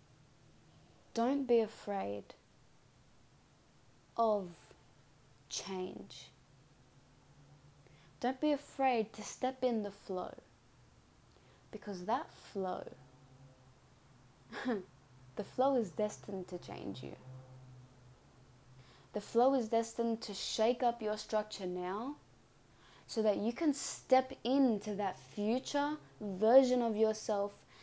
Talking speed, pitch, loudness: 95 wpm, 205 Hz, -36 LUFS